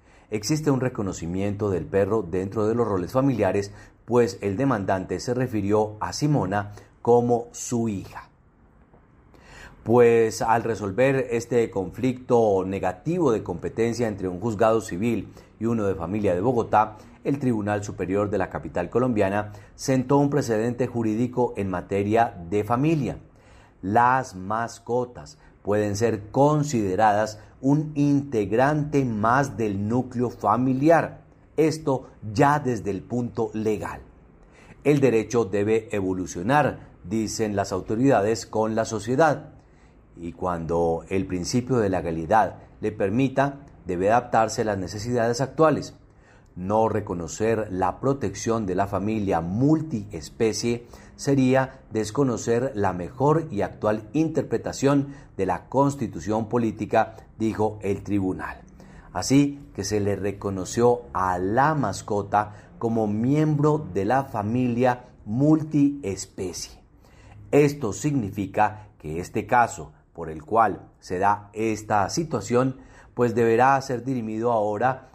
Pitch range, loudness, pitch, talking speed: 100-130 Hz, -24 LUFS, 110 Hz, 115 wpm